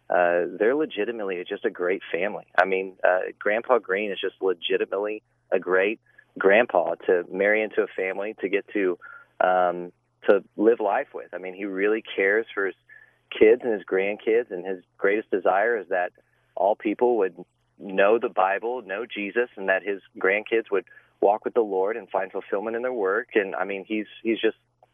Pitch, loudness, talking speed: 120 Hz, -24 LUFS, 185 wpm